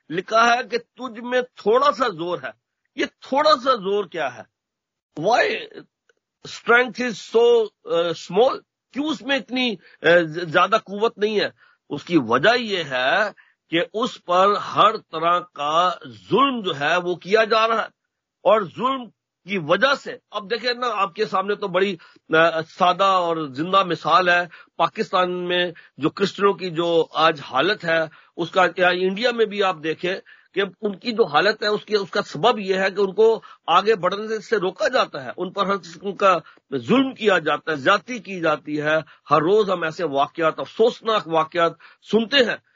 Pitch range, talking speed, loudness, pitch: 175-235 Hz, 165 wpm, -21 LUFS, 200 Hz